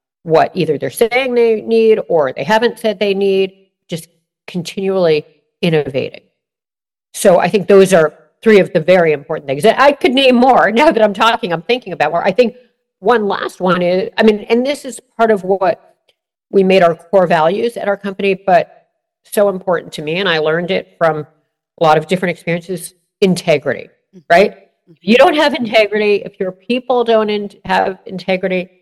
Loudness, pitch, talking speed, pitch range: -13 LUFS, 195 Hz, 185 wpm, 175-225 Hz